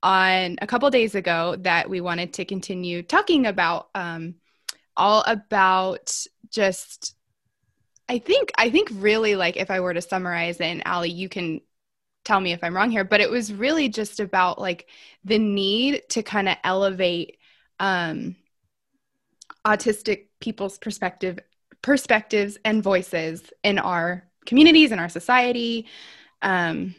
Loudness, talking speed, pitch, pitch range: -22 LUFS, 145 wpm, 195 Hz, 175-220 Hz